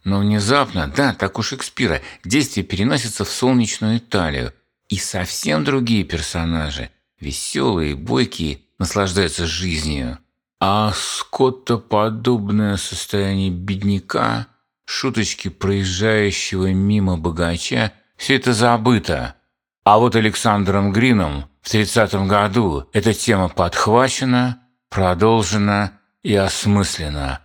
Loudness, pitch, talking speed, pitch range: -18 LUFS, 100 Hz, 95 wpm, 95-115 Hz